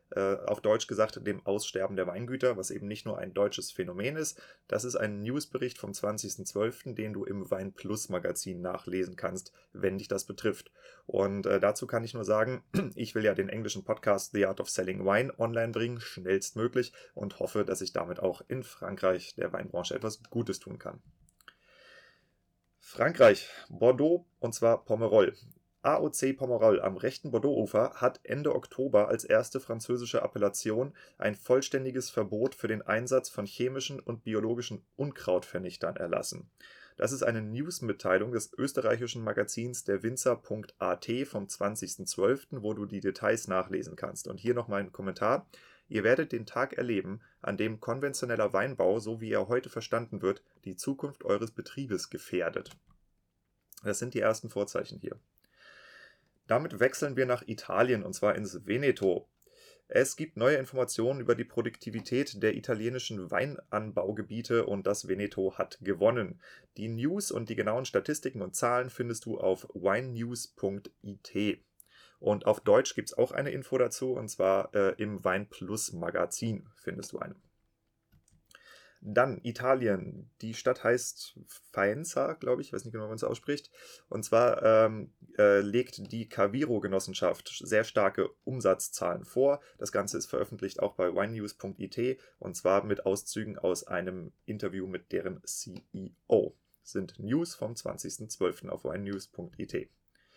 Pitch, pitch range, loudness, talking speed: 110 Hz, 100-125 Hz, -31 LUFS, 150 wpm